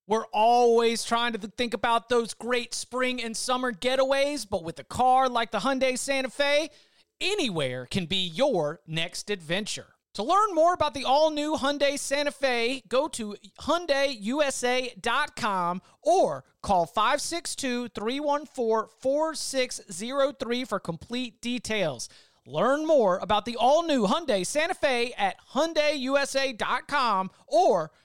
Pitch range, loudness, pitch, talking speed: 225-280 Hz, -26 LUFS, 250 Hz, 120 wpm